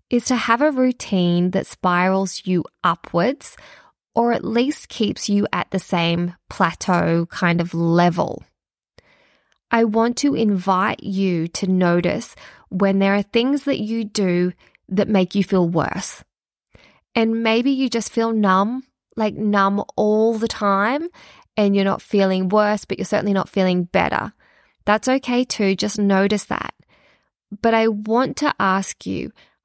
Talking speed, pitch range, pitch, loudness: 150 wpm, 190-230 Hz, 205 Hz, -20 LUFS